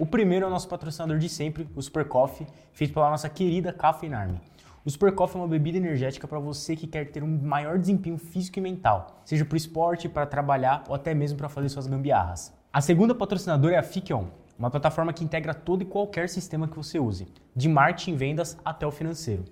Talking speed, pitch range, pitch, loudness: 220 wpm, 145-170 Hz, 155 Hz, -27 LUFS